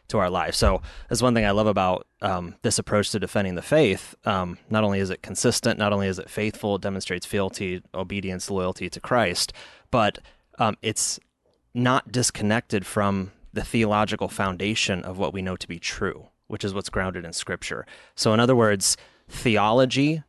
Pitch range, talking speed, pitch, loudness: 95-110 Hz, 185 wpm, 105 Hz, -24 LUFS